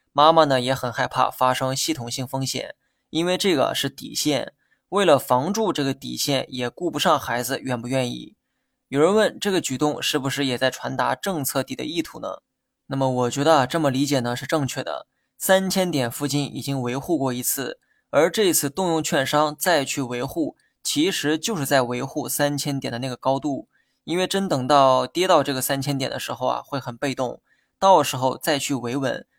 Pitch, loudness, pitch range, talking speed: 140 Hz, -22 LUFS, 130-160 Hz, 285 characters per minute